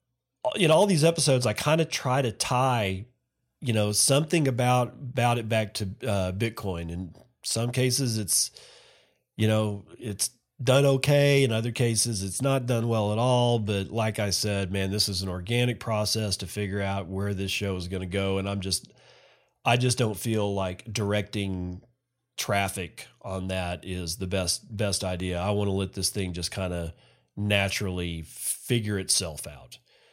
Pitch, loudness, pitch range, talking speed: 105 Hz, -26 LUFS, 95-120 Hz, 175 wpm